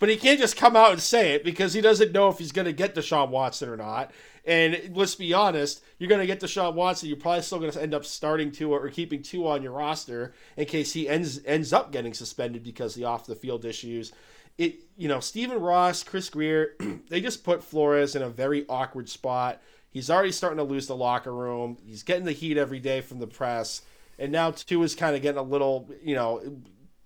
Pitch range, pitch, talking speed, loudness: 130-175 Hz, 150 Hz, 230 wpm, -26 LUFS